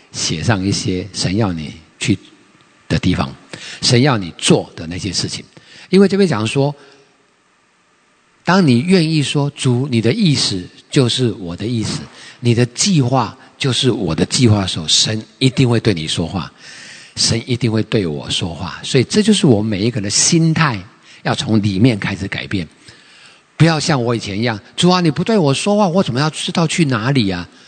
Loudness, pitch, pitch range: -16 LUFS, 125 Hz, 110-150 Hz